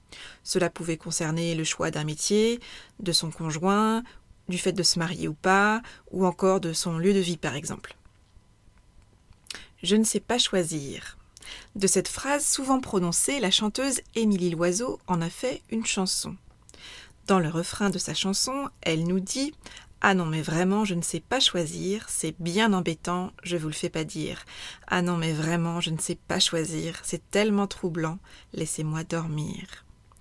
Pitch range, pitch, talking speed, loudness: 160-200 Hz, 175 Hz, 170 wpm, -26 LUFS